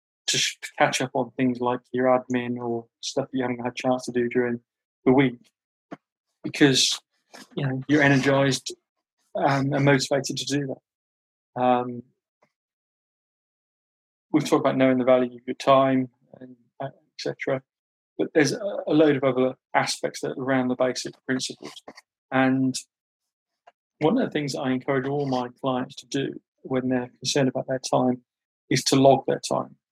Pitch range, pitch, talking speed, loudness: 125-135 Hz, 130 Hz, 155 wpm, -24 LUFS